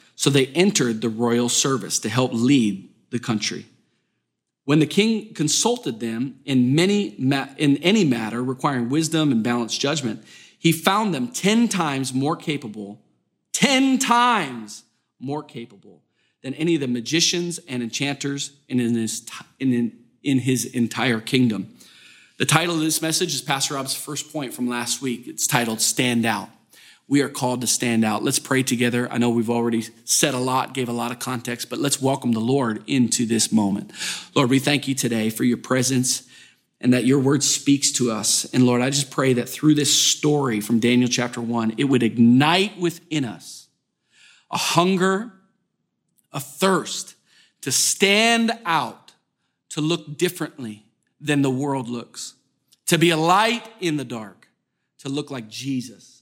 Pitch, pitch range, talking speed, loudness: 135 Hz, 120-155 Hz, 170 wpm, -21 LUFS